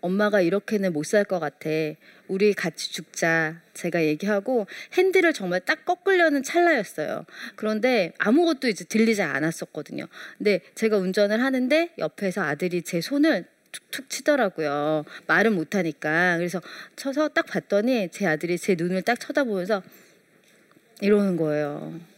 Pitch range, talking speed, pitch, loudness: 175-250 Hz, 315 characters per minute, 200 Hz, -24 LUFS